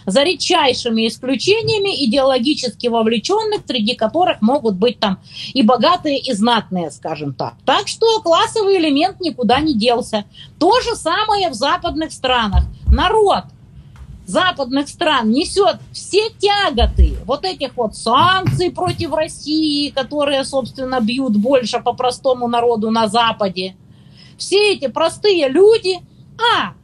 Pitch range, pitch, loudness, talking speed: 240-360 Hz, 275 Hz, -16 LUFS, 125 wpm